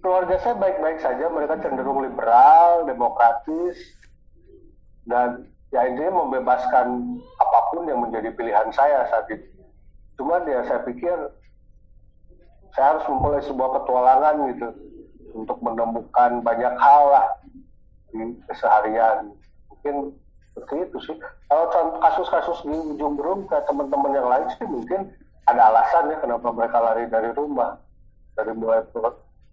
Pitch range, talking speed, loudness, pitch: 115-170 Hz, 125 wpm, -20 LUFS, 130 Hz